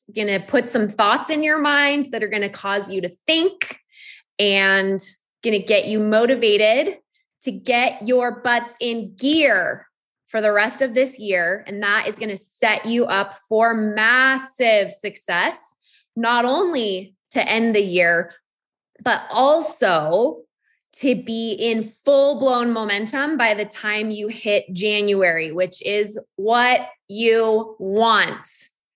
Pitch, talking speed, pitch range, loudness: 220 Hz, 145 wpm, 205-255 Hz, -19 LUFS